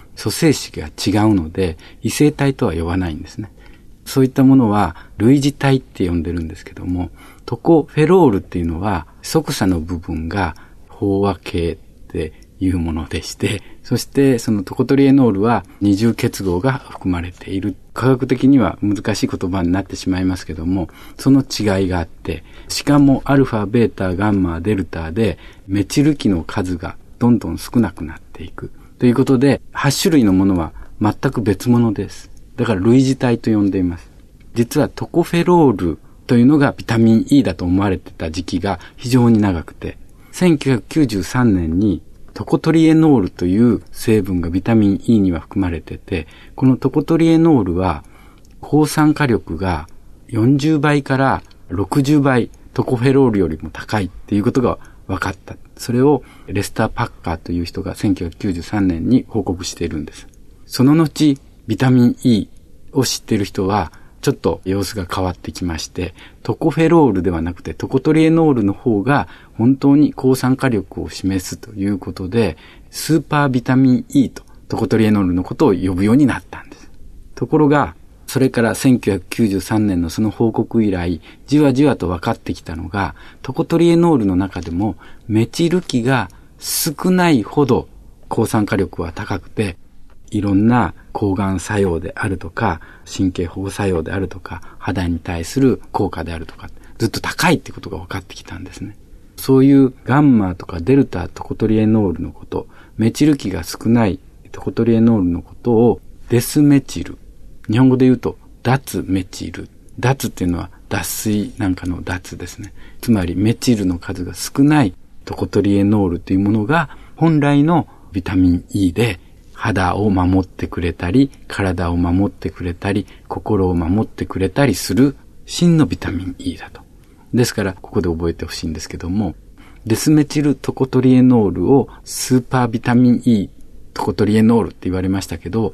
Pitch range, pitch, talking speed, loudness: 90-130 Hz, 100 Hz, 335 characters per minute, -17 LUFS